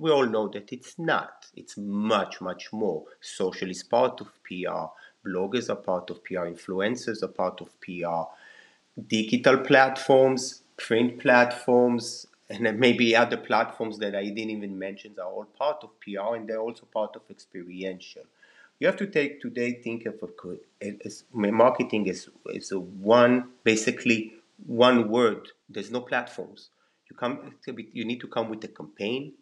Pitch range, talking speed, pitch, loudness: 100-125 Hz, 165 wpm, 115 Hz, -26 LUFS